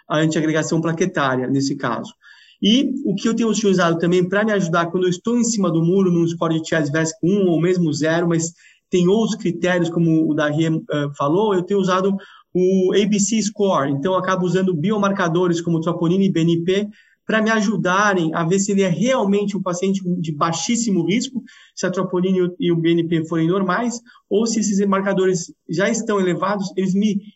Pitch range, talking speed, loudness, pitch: 170-200 Hz, 185 wpm, -19 LUFS, 185 Hz